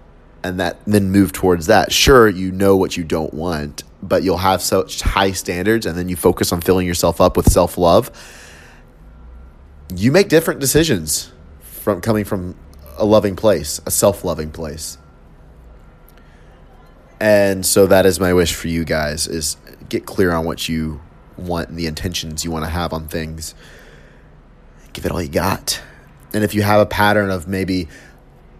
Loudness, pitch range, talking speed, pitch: -17 LUFS, 80-95 Hz, 170 wpm, 85 Hz